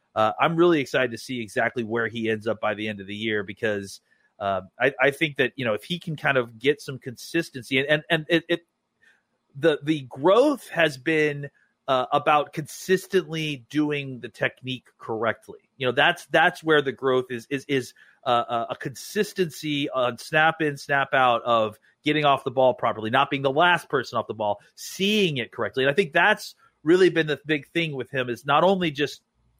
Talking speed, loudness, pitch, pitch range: 205 wpm, -24 LUFS, 140 Hz, 120-160 Hz